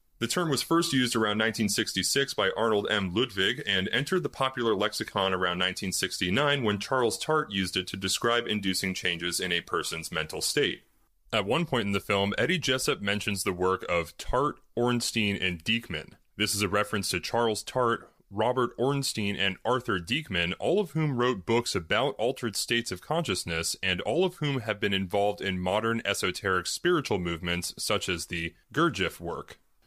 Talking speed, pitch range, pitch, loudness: 175 wpm, 95-120 Hz, 105 Hz, -28 LUFS